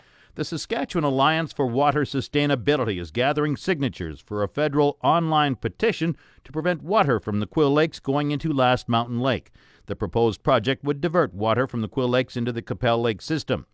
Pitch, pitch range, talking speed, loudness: 135 Hz, 115-150 Hz, 180 wpm, -23 LUFS